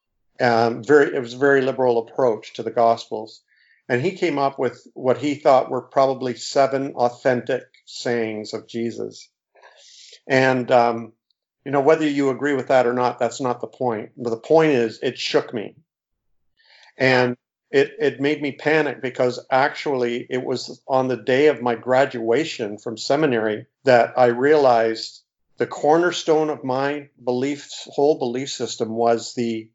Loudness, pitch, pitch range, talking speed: -21 LUFS, 125 Hz, 115-140 Hz, 160 wpm